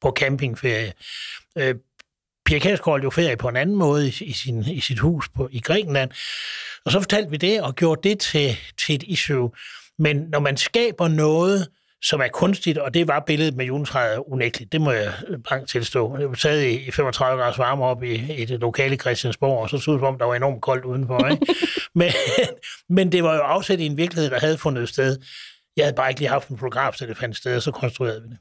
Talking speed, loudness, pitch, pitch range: 220 wpm, -22 LUFS, 140 Hz, 125-160 Hz